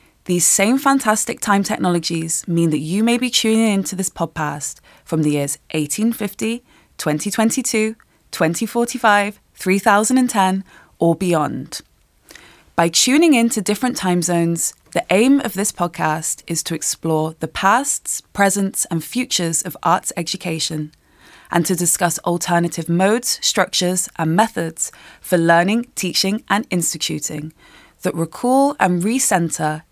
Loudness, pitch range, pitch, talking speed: -18 LUFS, 165-220 Hz, 185 Hz, 125 wpm